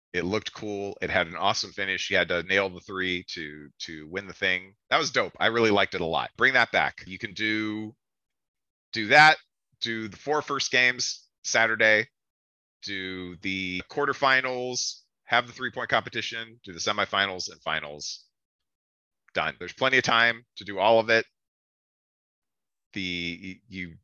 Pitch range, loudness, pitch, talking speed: 90-115 Hz, -25 LUFS, 100 Hz, 165 wpm